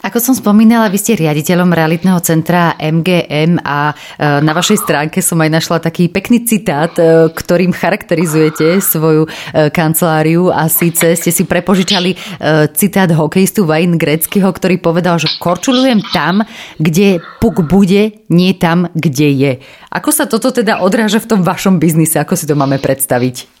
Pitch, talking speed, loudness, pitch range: 175 Hz, 145 wpm, -11 LUFS, 160-195 Hz